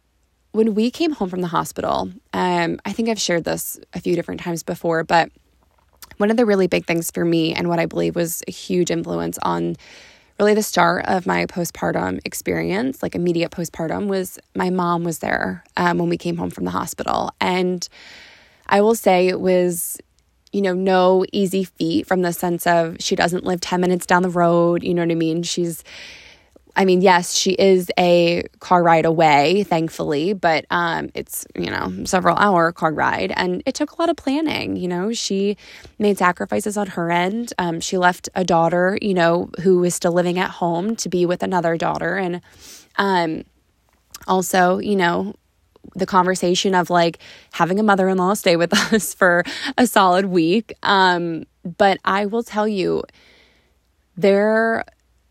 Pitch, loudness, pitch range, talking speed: 180 Hz, -19 LUFS, 170-195 Hz, 180 wpm